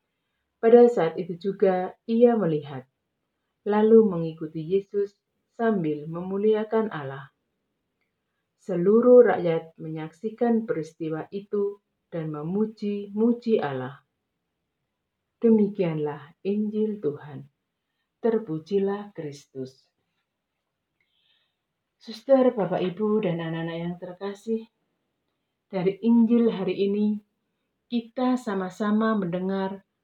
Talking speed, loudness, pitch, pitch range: 80 wpm, -24 LUFS, 195 Hz, 165-220 Hz